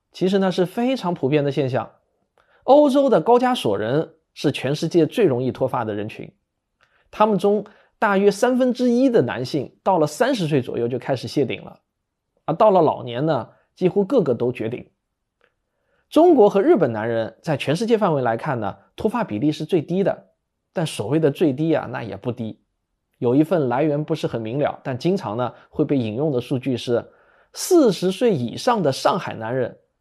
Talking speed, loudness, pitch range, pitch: 270 characters per minute, -20 LUFS, 125-205 Hz, 155 Hz